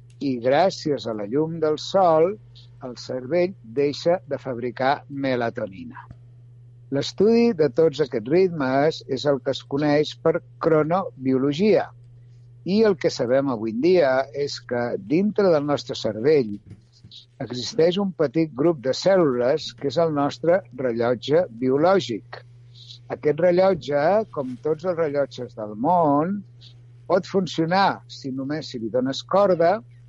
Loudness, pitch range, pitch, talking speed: -22 LUFS, 120-165 Hz, 140 Hz, 130 wpm